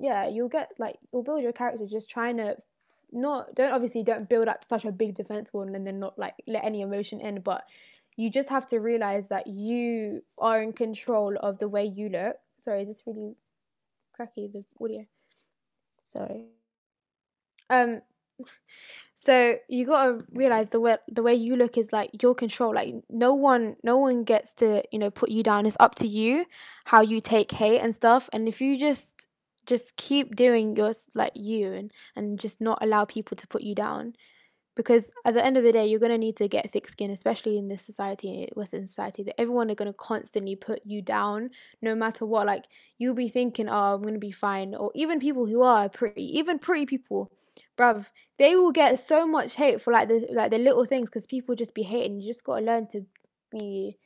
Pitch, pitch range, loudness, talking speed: 225 Hz, 210-245 Hz, -26 LUFS, 210 wpm